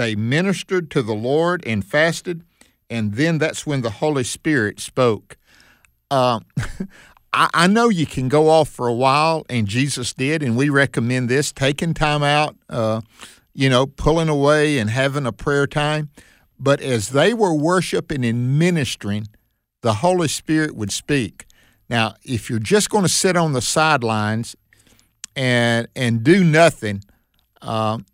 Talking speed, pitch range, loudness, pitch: 155 wpm, 115-155 Hz, -19 LUFS, 135 Hz